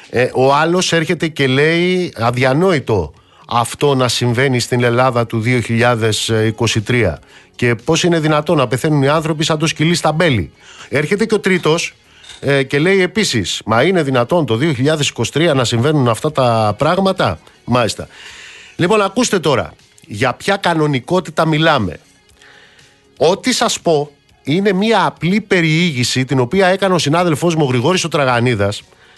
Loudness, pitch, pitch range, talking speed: -14 LUFS, 150 Hz, 125-175 Hz, 140 wpm